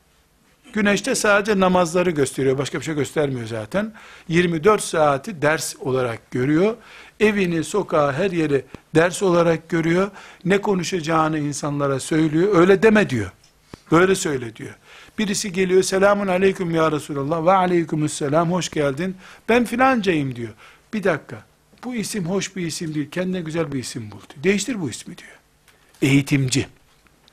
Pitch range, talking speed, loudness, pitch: 145-195 Hz, 140 wpm, -20 LUFS, 170 Hz